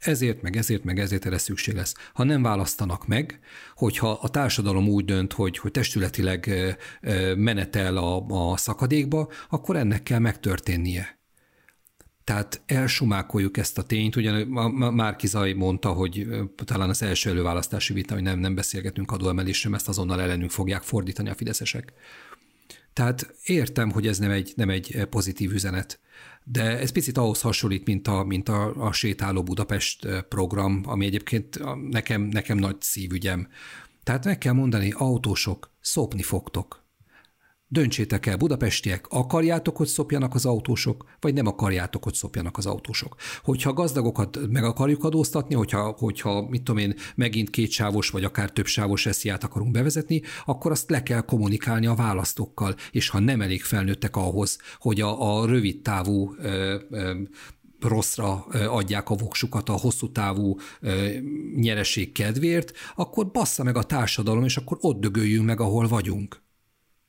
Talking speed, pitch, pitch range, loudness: 150 wpm, 105 Hz, 100-120 Hz, -25 LUFS